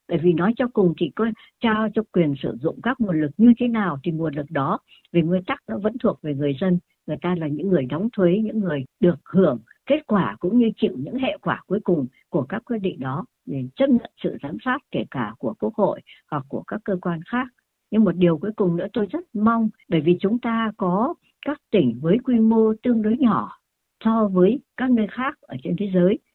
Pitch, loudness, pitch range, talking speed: 205 Hz, -22 LUFS, 175-230 Hz, 240 wpm